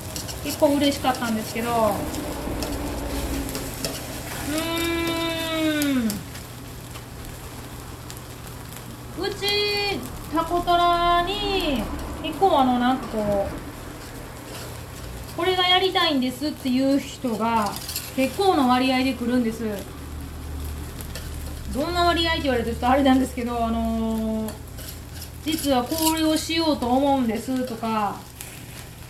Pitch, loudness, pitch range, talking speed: 265 Hz, -23 LUFS, 230-330 Hz, 200 characters per minute